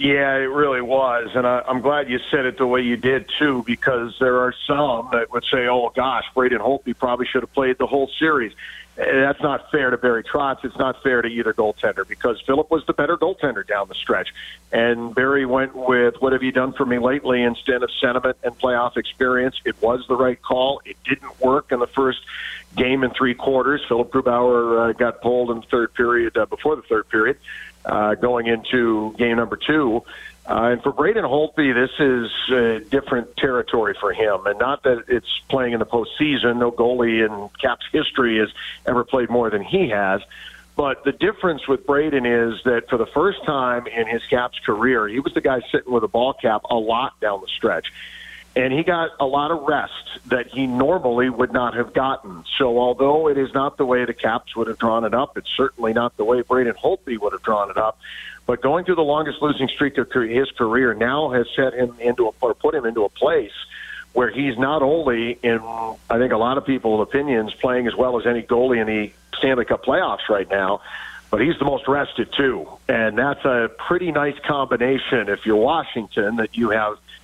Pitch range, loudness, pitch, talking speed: 120-135 Hz, -20 LUFS, 125 Hz, 215 wpm